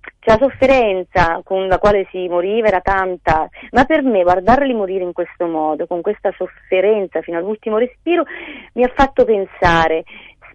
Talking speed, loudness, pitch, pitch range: 160 wpm, -16 LUFS, 195 Hz, 175-240 Hz